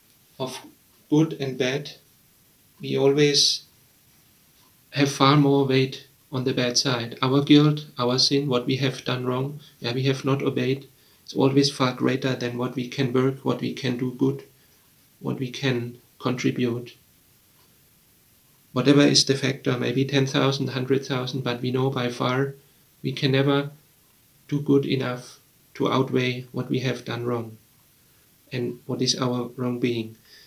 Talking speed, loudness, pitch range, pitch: 150 wpm, -23 LUFS, 125-140 Hz, 135 Hz